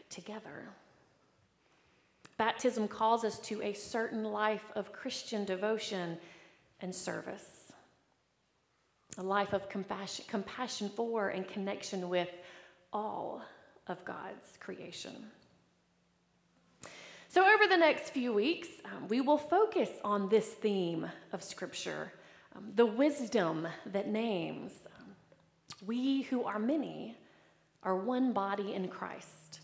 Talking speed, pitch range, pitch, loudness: 115 wpm, 195-245 Hz, 215 Hz, -34 LUFS